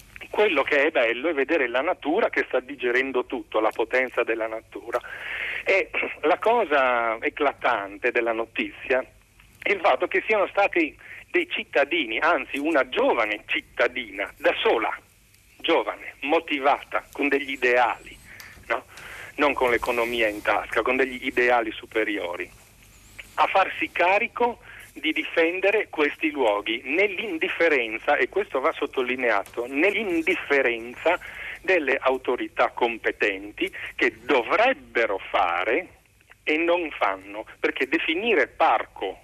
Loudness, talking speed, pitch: -24 LUFS, 115 wpm, 155 Hz